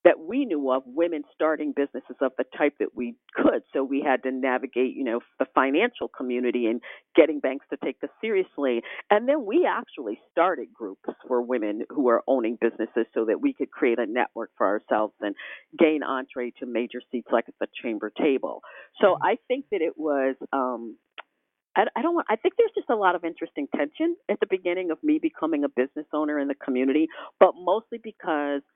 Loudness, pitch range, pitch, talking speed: -26 LUFS, 130-210 Hz, 150 Hz, 205 wpm